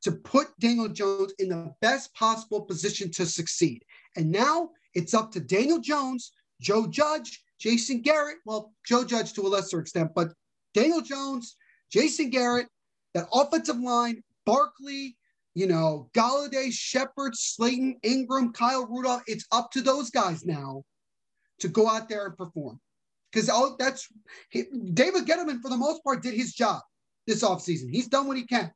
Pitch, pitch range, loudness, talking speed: 240 Hz, 200-270 Hz, -27 LUFS, 160 wpm